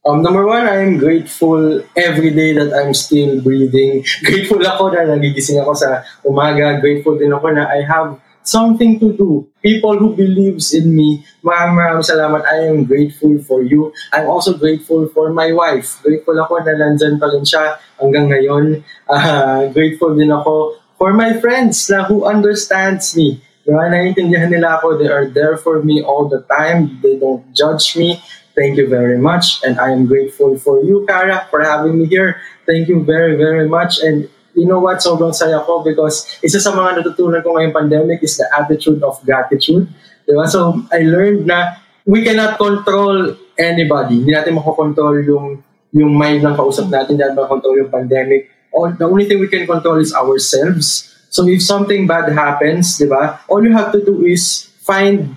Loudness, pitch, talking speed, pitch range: -12 LUFS, 160 Hz, 170 wpm, 145-180 Hz